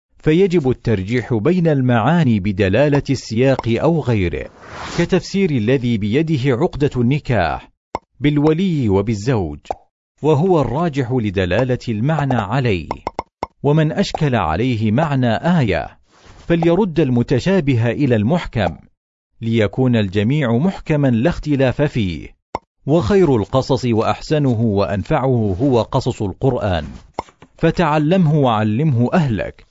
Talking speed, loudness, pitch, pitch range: 90 wpm, -17 LUFS, 130 Hz, 115-155 Hz